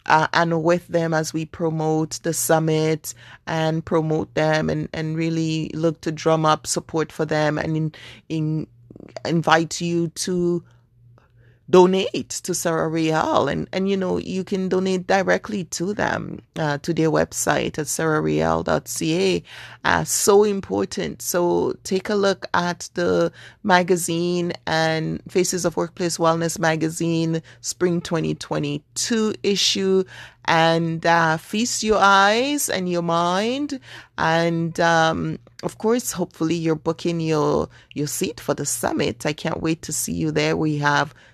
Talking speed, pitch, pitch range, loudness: 140 wpm, 165 Hz, 155-180 Hz, -21 LUFS